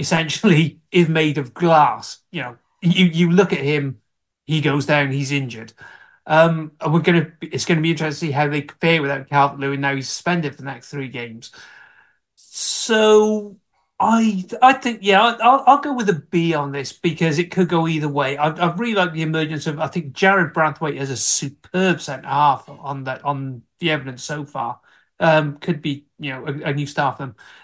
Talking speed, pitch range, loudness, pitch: 205 wpm, 140-175 Hz, -19 LUFS, 155 Hz